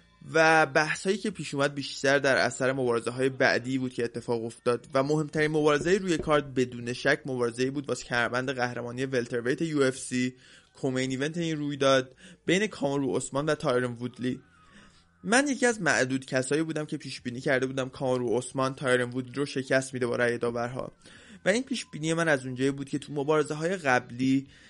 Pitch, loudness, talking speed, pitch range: 135 Hz, -28 LUFS, 180 wpm, 125-150 Hz